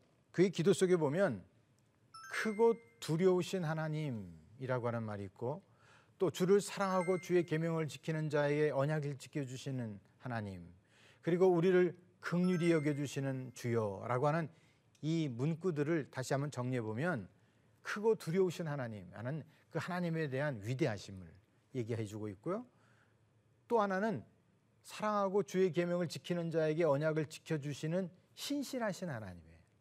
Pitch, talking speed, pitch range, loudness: 145 Hz, 310 characters per minute, 120-175 Hz, -36 LUFS